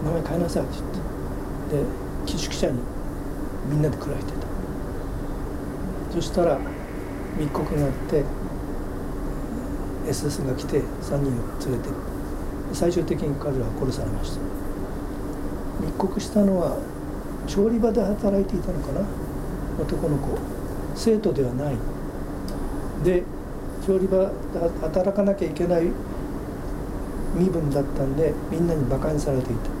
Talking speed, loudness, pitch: 240 characters per minute, -26 LUFS, 145 Hz